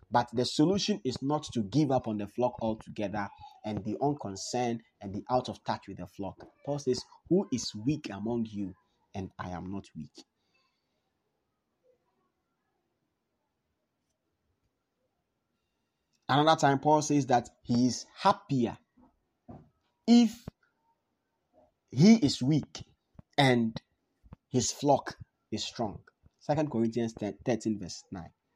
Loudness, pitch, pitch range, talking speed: -30 LUFS, 125 Hz, 105-150 Hz, 120 wpm